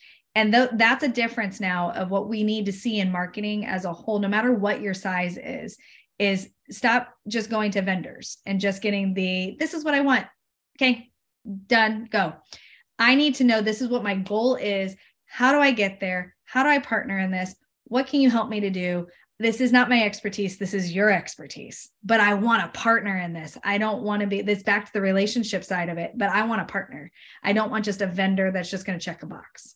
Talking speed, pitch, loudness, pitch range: 235 wpm, 205 Hz, -23 LUFS, 190-230 Hz